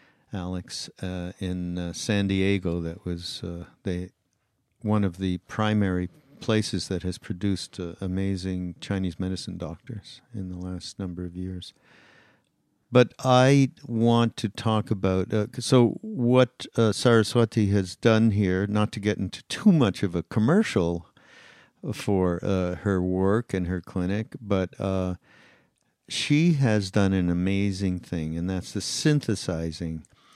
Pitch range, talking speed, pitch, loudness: 90-110 Hz, 140 wpm, 95 Hz, -26 LUFS